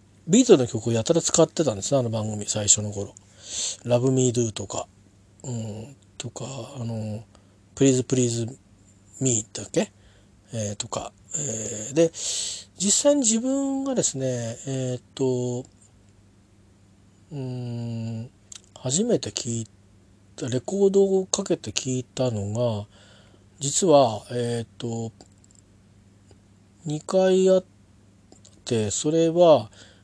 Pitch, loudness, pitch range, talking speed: 115 Hz, -24 LUFS, 100-130 Hz, 215 characters per minute